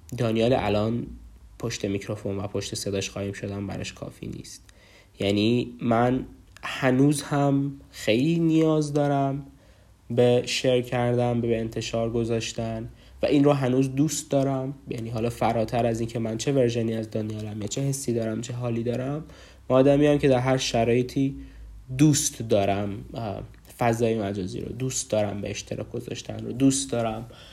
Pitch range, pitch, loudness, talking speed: 105-130 Hz, 115 Hz, -25 LUFS, 150 wpm